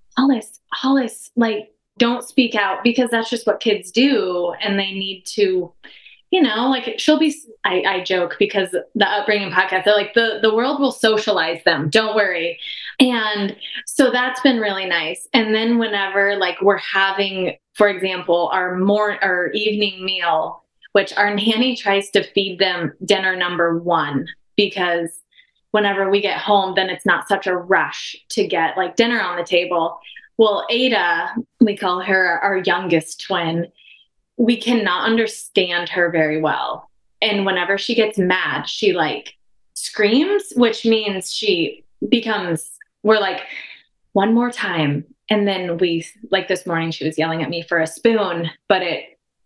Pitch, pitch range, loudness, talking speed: 200 Hz, 180-230 Hz, -18 LUFS, 160 wpm